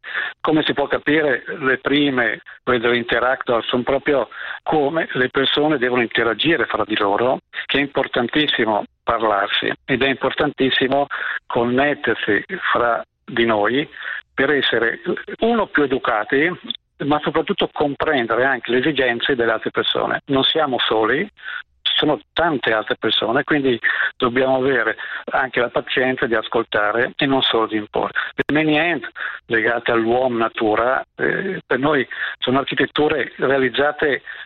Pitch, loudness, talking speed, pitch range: 130 Hz, -19 LUFS, 130 wpm, 120-140 Hz